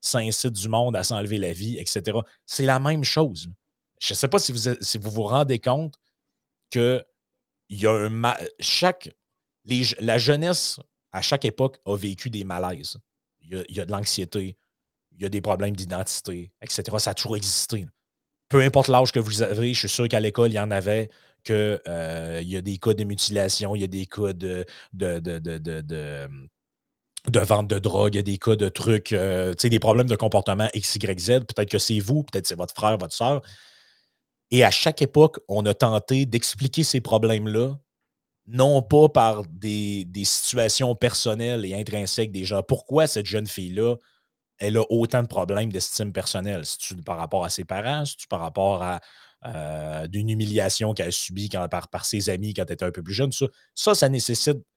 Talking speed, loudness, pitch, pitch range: 205 wpm, -24 LUFS, 105 Hz, 95-125 Hz